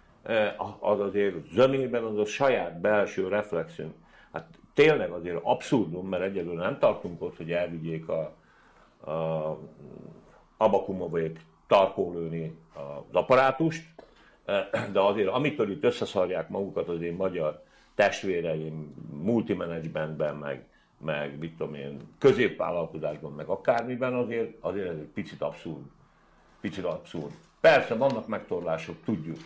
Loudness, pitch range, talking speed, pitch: -28 LUFS, 80-110 Hz, 115 wpm, 85 Hz